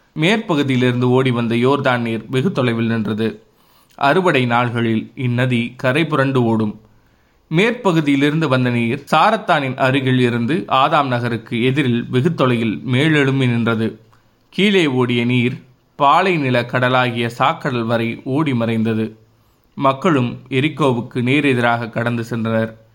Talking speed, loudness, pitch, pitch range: 105 wpm, -17 LUFS, 125 Hz, 115-135 Hz